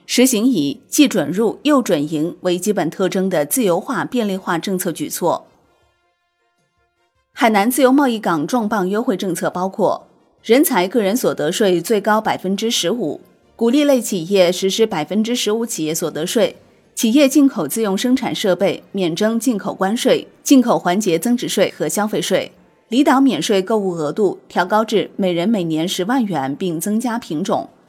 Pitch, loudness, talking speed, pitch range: 200 Hz, -17 LUFS, 260 characters per minute, 175-240 Hz